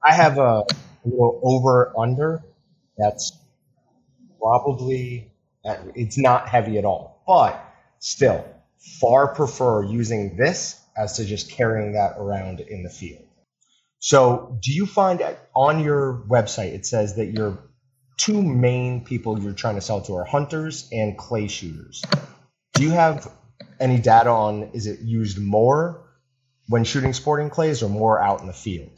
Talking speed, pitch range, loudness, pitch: 150 wpm, 105-135 Hz, -21 LUFS, 120 Hz